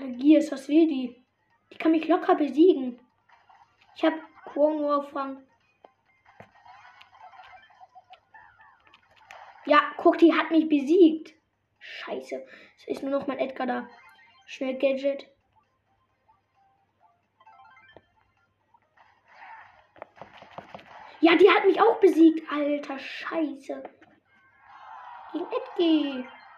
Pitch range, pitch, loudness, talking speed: 280-365 Hz, 315 Hz, -24 LUFS, 85 wpm